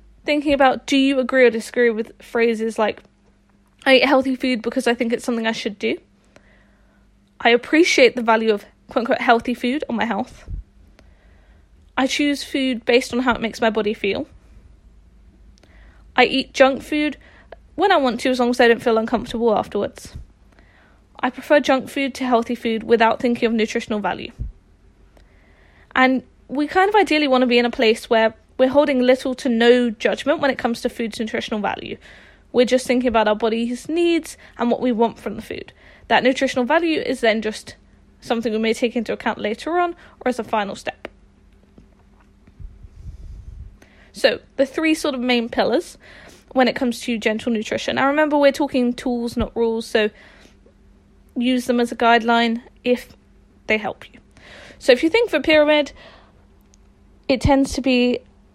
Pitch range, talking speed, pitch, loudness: 225-265 Hz, 175 wpm, 245 Hz, -19 LUFS